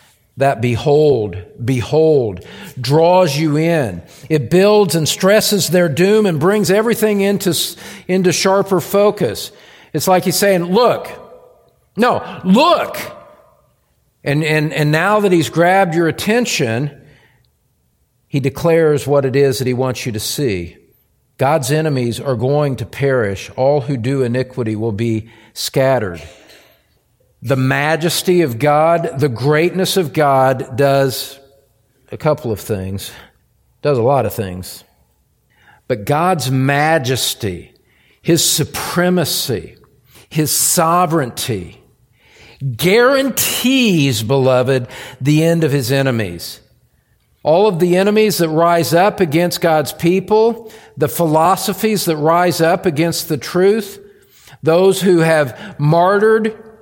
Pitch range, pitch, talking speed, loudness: 130-180 Hz, 155 Hz, 120 wpm, -15 LUFS